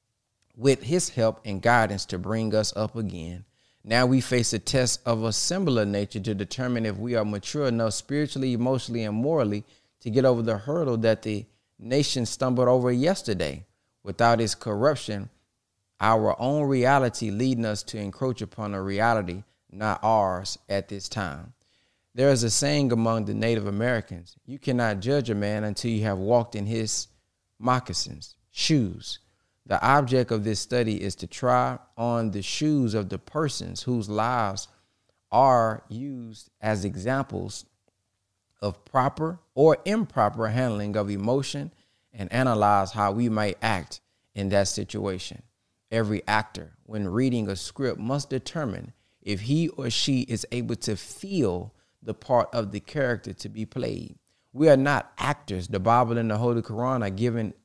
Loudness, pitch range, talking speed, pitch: -26 LUFS, 100-125 Hz, 160 wpm, 110 Hz